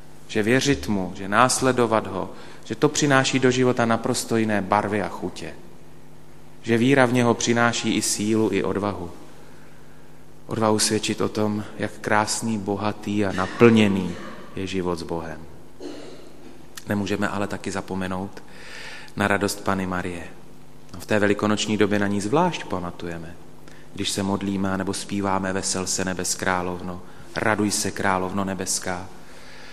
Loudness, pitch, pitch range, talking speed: -23 LUFS, 100 Hz, 95-110 Hz, 135 wpm